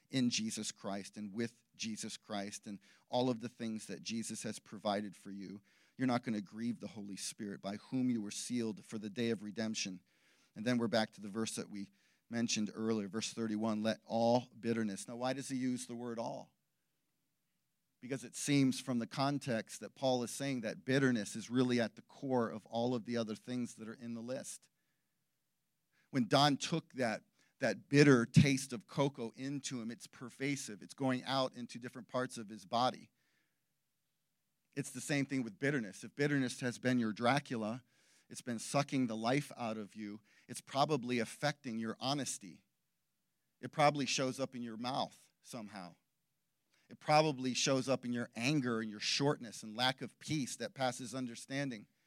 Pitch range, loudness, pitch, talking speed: 110-130 Hz, -37 LUFS, 120 Hz, 185 wpm